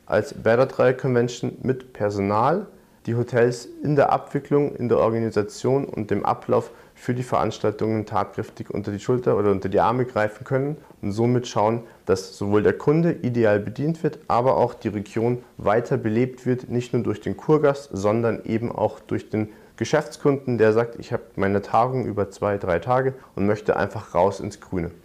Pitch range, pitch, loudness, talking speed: 105-130 Hz, 120 Hz, -23 LUFS, 175 wpm